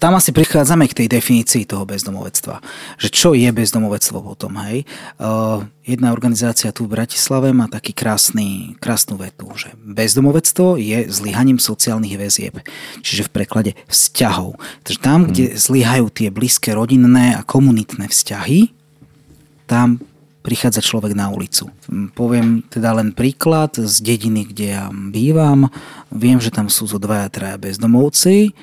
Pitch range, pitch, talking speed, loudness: 110-135 Hz, 120 Hz, 145 wpm, -15 LUFS